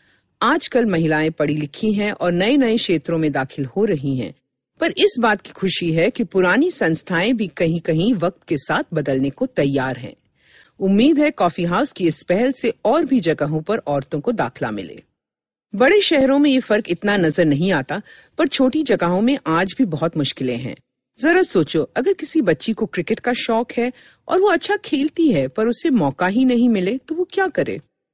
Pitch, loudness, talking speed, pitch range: 205 Hz, -19 LUFS, 195 wpm, 165-260 Hz